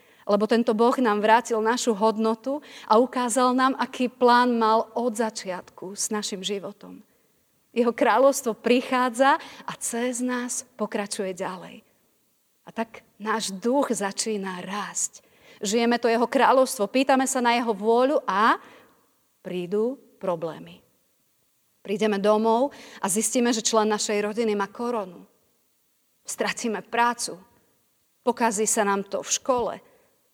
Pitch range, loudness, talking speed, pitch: 210-245 Hz, -24 LUFS, 125 wpm, 230 Hz